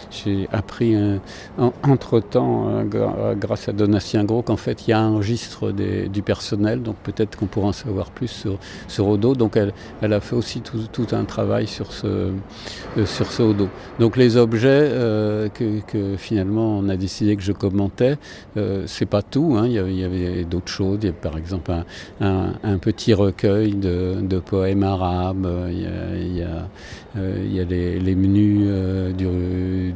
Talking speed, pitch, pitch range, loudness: 205 wpm, 100 Hz, 95-110 Hz, -21 LUFS